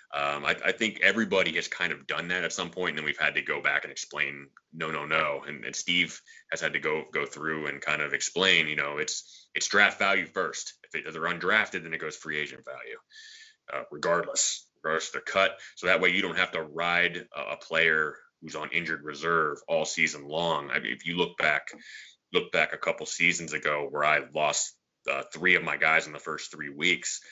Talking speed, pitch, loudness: 230 wpm, 80 Hz, -27 LUFS